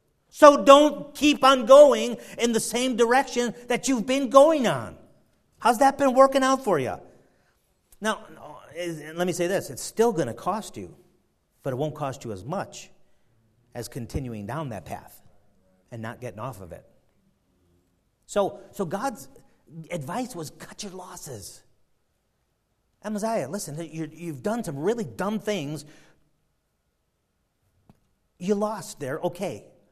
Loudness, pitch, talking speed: -23 LUFS, 175 Hz, 140 wpm